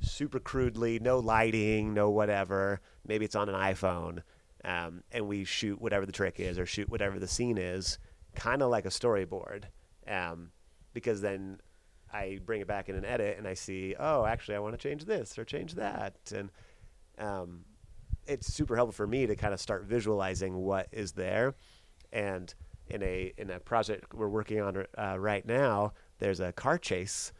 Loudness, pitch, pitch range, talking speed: -33 LUFS, 100 Hz, 95-110 Hz, 185 wpm